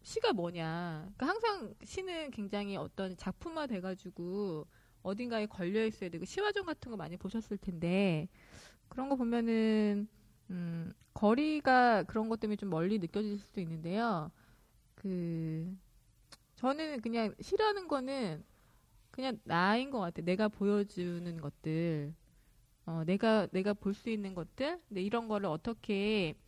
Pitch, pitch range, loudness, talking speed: 205 Hz, 175-235 Hz, -35 LUFS, 275 characters per minute